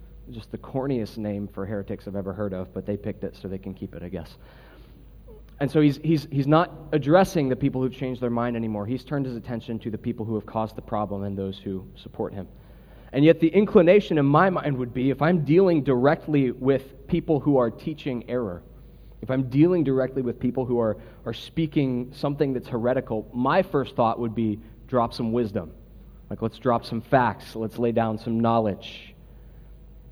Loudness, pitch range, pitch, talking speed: -24 LUFS, 110-140 Hz, 120 Hz, 205 wpm